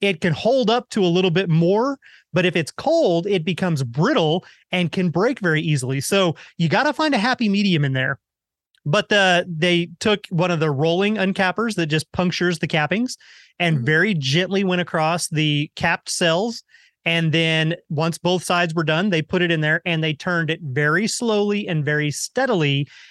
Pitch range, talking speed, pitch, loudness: 160-195 Hz, 190 wpm, 175 Hz, -20 LUFS